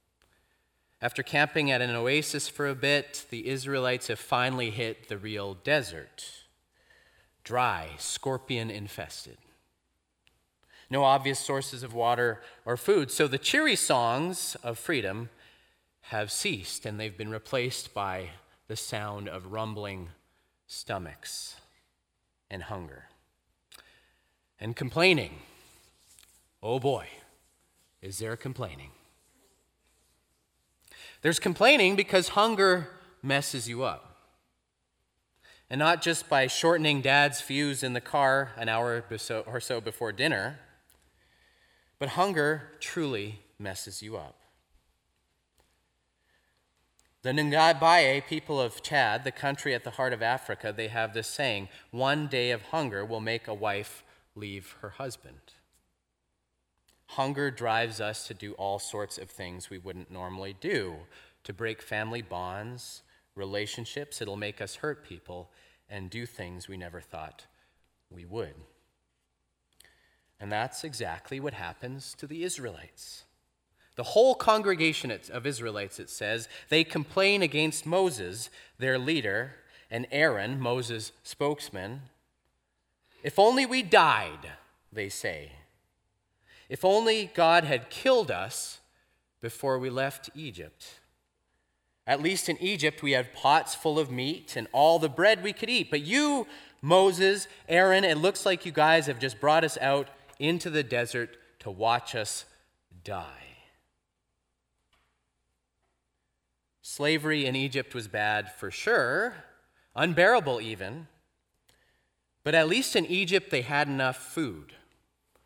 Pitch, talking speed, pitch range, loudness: 120 Hz, 125 wpm, 90-145 Hz, -28 LUFS